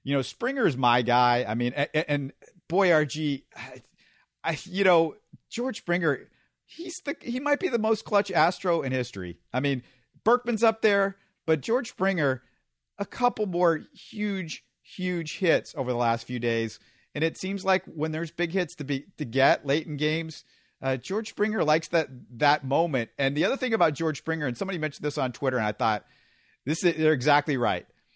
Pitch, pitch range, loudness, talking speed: 155 Hz, 135-195 Hz, -27 LUFS, 190 wpm